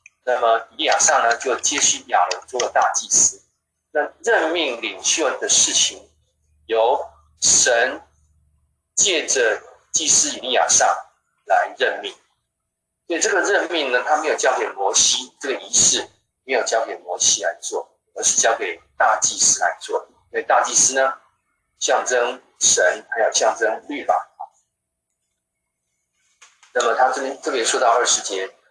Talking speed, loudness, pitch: 210 characters per minute, -18 LUFS, 75 Hz